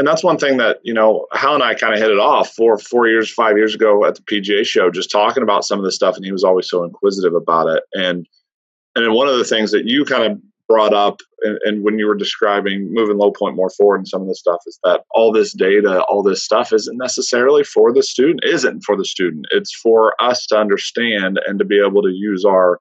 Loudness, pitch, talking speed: -15 LUFS, 115 Hz, 255 wpm